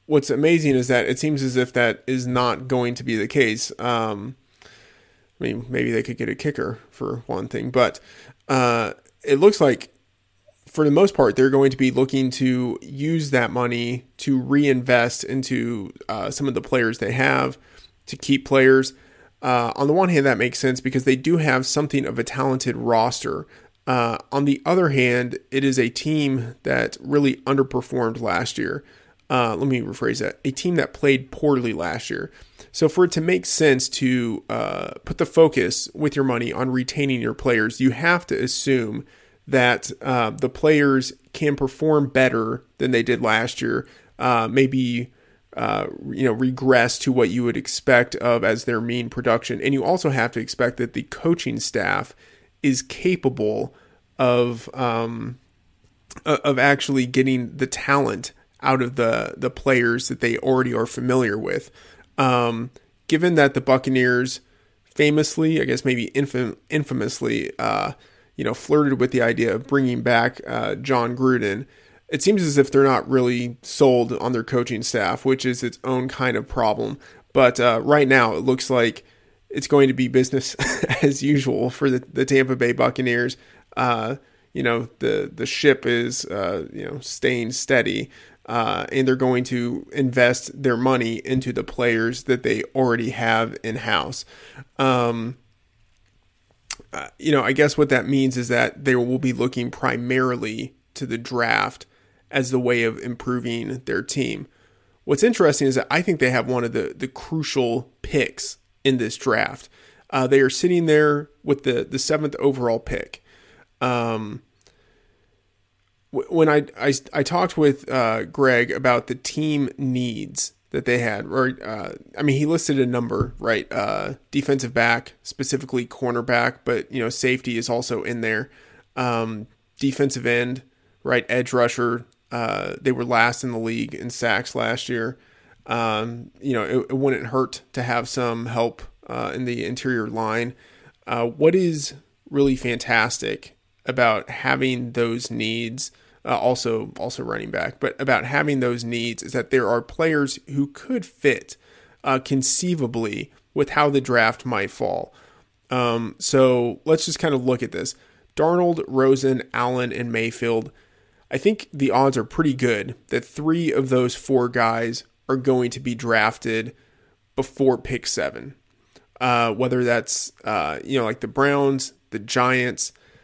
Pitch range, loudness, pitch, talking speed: 120-135 Hz, -21 LUFS, 130 Hz, 165 wpm